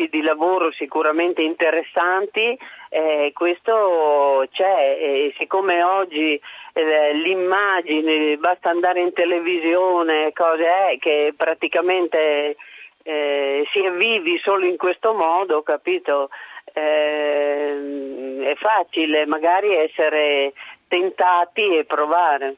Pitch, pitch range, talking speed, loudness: 160 Hz, 150-180 Hz, 95 wpm, -19 LUFS